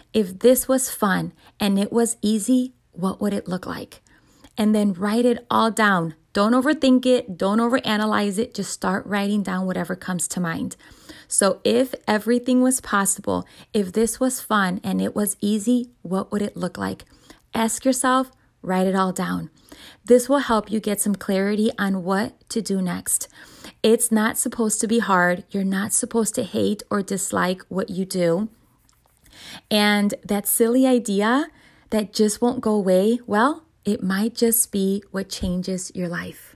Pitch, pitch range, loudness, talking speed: 210 Hz, 195-240 Hz, -21 LUFS, 170 wpm